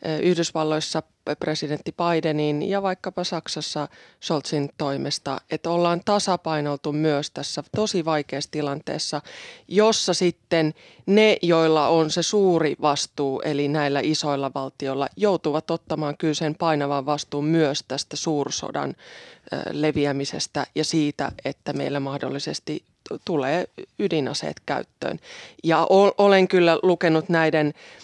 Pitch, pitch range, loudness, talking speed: 155 Hz, 145-170 Hz, -23 LUFS, 105 wpm